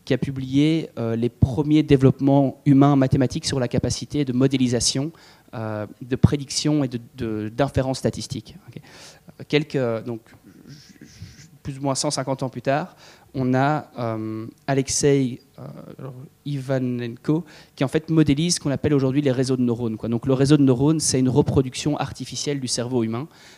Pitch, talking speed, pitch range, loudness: 135 Hz, 160 wpm, 125-145 Hz, -22 LUFS